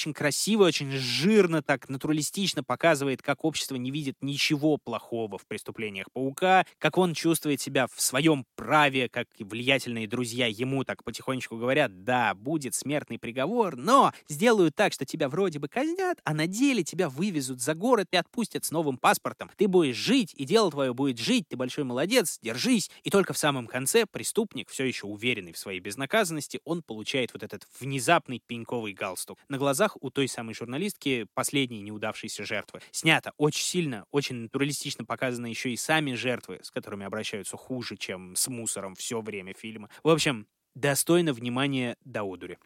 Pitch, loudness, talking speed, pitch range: 135 Hz, -27 LUFS, 170 wpm, 120-160 Hz